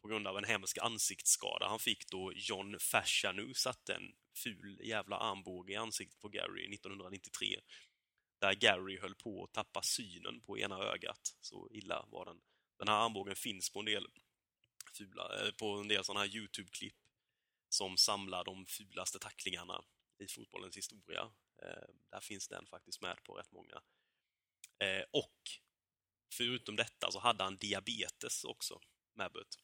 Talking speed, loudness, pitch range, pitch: 150 wpm, -39 LUFS, 95-110 Hz, 100 Hz